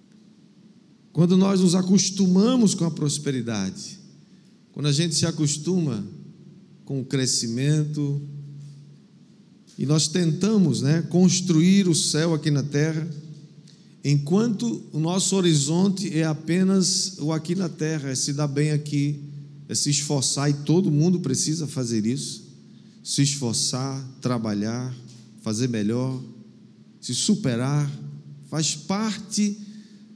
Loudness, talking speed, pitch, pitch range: -23 LUFS, 115 wpm, 155 Hz, 140-185 Hz